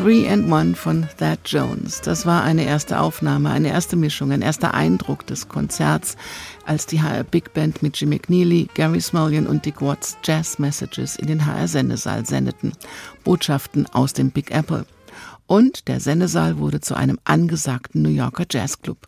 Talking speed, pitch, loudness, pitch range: 170 wpm, 150 Hz, -20 LUFS, 135-165 Hz